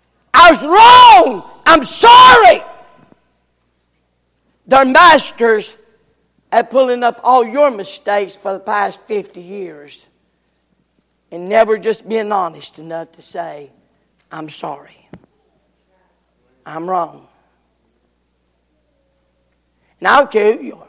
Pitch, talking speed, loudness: 200 Hz, 100 wpm, -9 LUFS